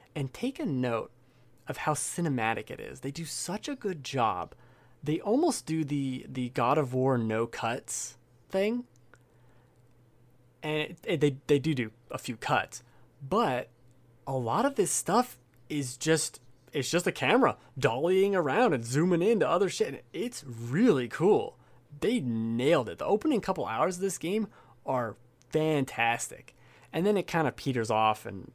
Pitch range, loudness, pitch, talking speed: 120-165 Hz, -29 LUFS, 130 Hz, 165 wpm